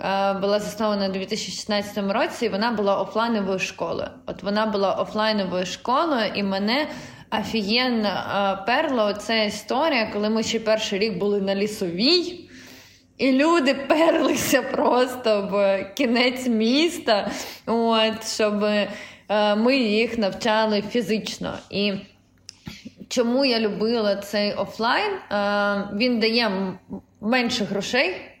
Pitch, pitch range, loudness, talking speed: 215 Hz, 200-245 Hz, -22 LUFS, 110 wpm